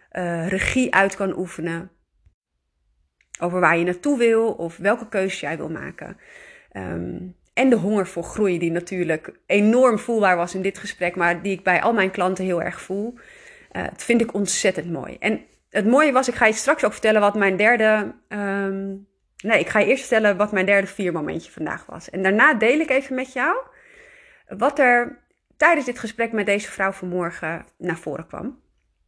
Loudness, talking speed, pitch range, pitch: -21 LUFS, 190 wpm, 180-235 Hz, 200 Hz